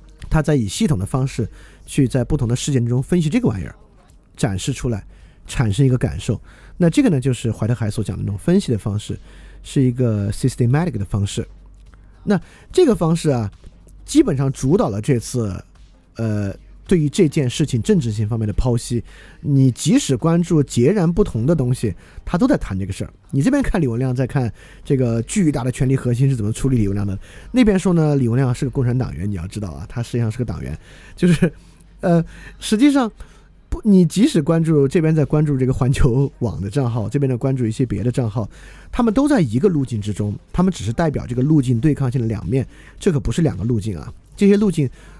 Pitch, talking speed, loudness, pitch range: 130 Hz, 325 characters per minute, -19 LUFS, 105-150 Hz